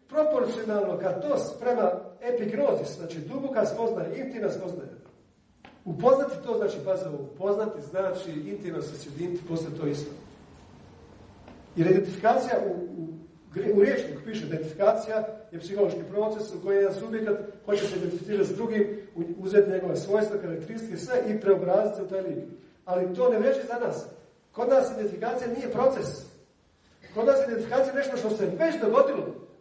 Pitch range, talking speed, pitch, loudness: 180-230 Hz, 150 wpm, 205 Hz, -27 LUFS